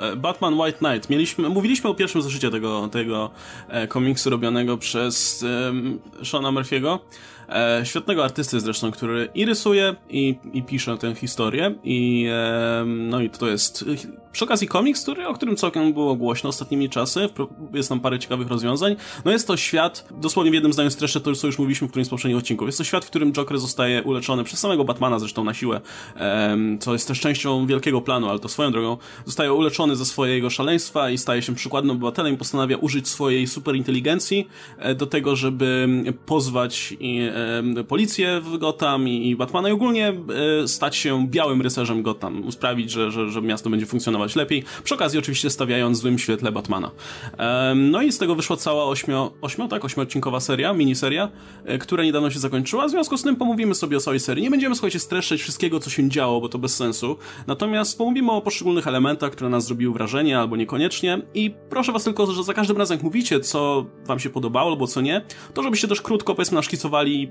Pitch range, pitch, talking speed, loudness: 120-160 Hz, 135 Hz, 190 wpm, -22 LUFS